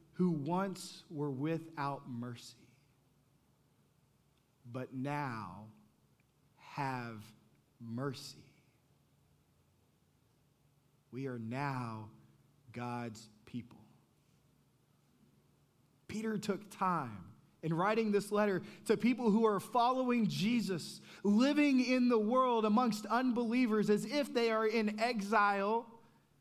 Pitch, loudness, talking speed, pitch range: 170 Hz, -34 LUFS, 90 wpm, 135-220 Hz